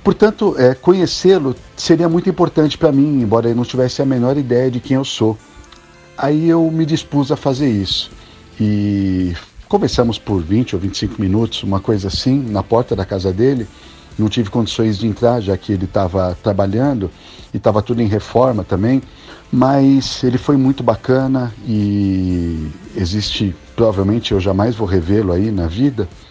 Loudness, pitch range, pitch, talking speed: -16 LUFS, 100-135 Hz, 115 Hz, 165 wpm